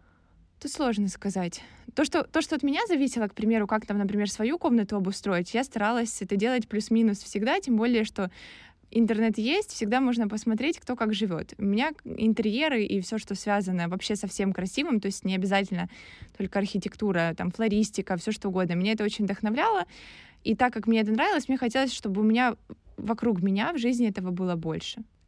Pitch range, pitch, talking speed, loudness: 200-240 Hz, 215 Hz, 190 wpm, -27 LUFS